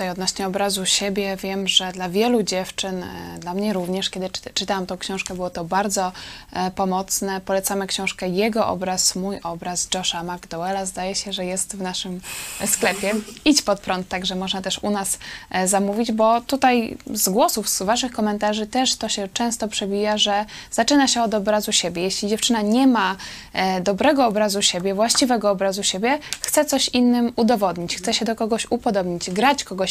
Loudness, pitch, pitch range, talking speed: -21 LUFS, 200 Hz, 185-225 Hz, 165 wpm